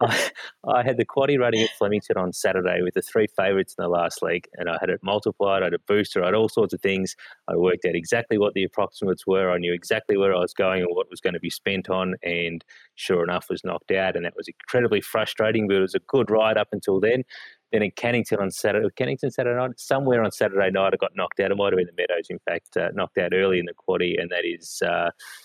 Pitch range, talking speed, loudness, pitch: 95-110 Hz, 260 wpm, -24 LUFS, 95 Hz